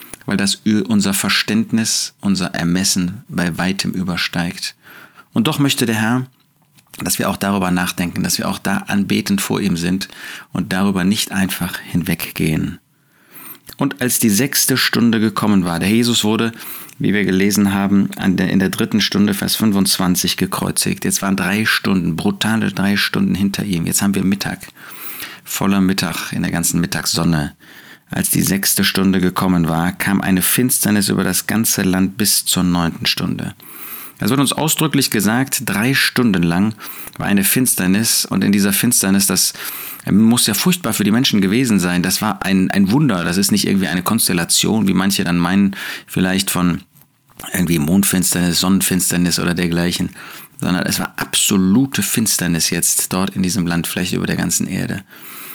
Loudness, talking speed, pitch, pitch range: -16 LUFS, 160 wpm, 100 Hz, 90-115 Hz